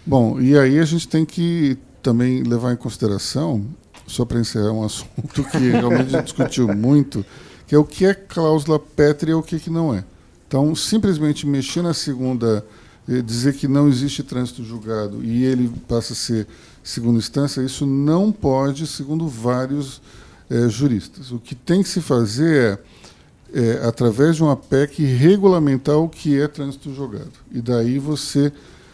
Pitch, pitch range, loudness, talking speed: 135 Hz, 120-150 Hz, -19 LUFS, 170 wpm